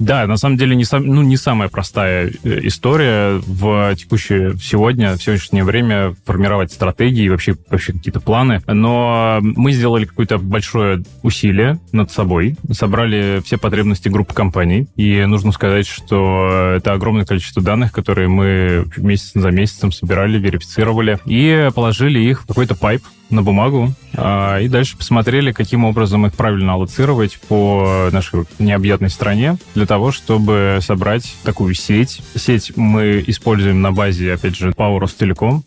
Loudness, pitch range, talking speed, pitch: -15 LUFS, 95-115 Hz, 150 wpm, 105 Hz